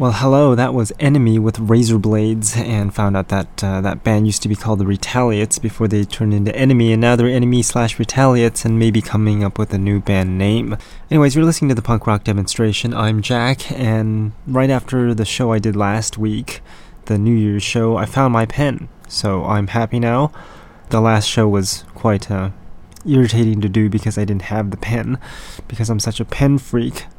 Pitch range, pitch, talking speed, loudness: 105-120 Hz, 110 Hz, 205 wpm, -16 LUFS